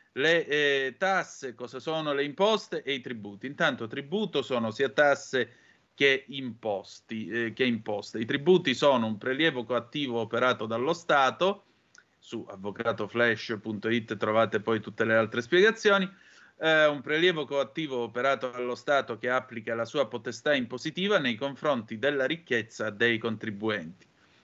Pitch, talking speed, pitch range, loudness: 125 Hz, 140 wpm, 115-145 Hz, -28 LUFS